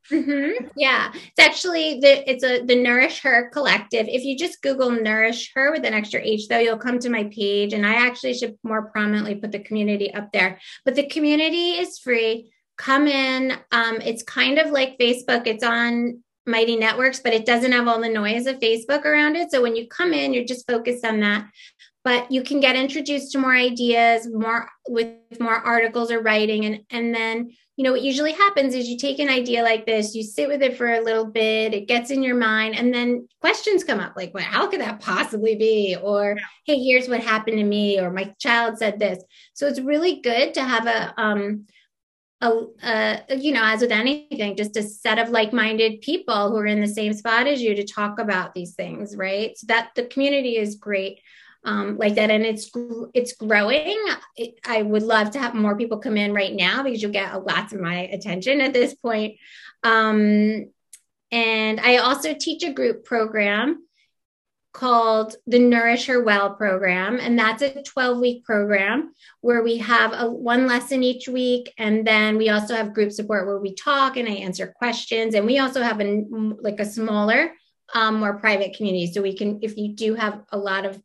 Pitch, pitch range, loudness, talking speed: 230 Hz, 215-255 Hz, -21 LUFS, 205 wpm